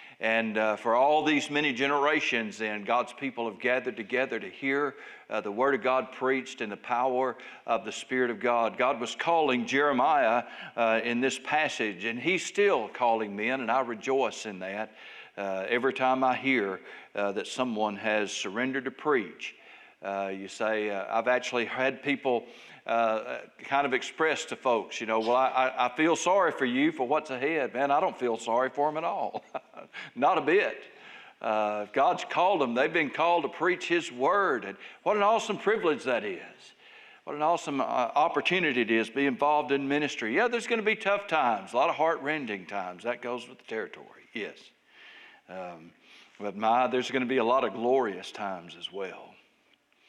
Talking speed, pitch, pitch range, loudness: 190 wpm, 130 Hz, 115-145 Hz, -28 LUFS